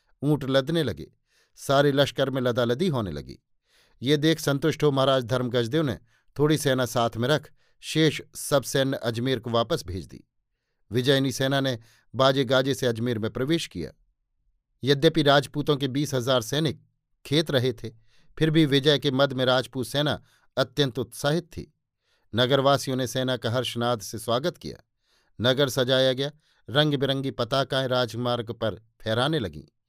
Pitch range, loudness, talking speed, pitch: 120-145 Hz, -25 LUFS, 155 wpm, 130 Hz